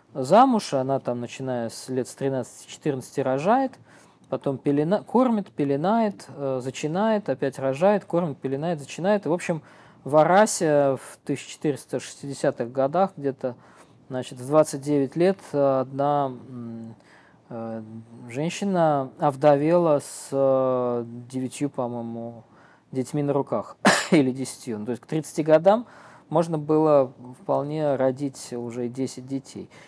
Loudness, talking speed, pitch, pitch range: -24 LUFS, 115 wpm, 140 Hz, 130-155 Hz